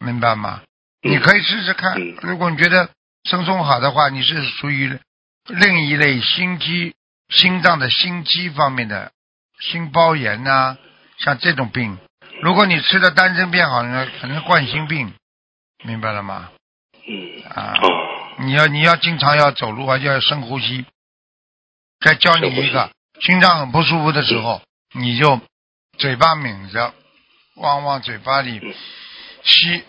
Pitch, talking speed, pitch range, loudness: 145 Hz, 215 characters per minute, 125-175 Hz, -16 LUFS